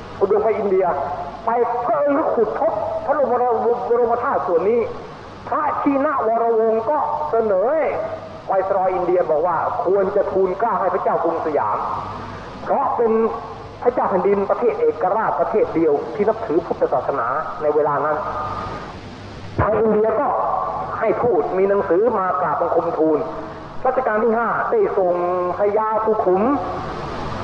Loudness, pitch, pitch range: -19 LUFS, 220 Hz, 185-240 Hz